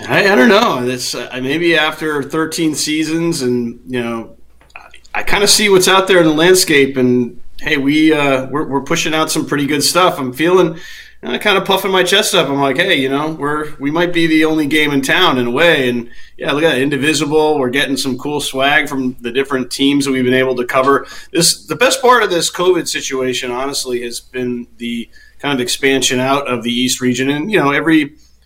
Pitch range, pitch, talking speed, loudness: 130-160 Hz, 140 Hz, 225 wpm, -14 LUFS